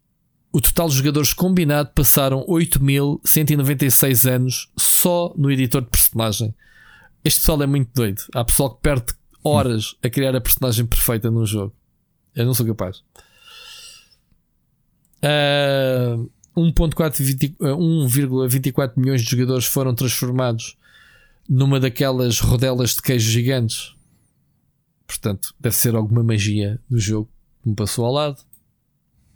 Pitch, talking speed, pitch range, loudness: 130 Hz, 120 wpm, 120-145 Hz, -18 LUFS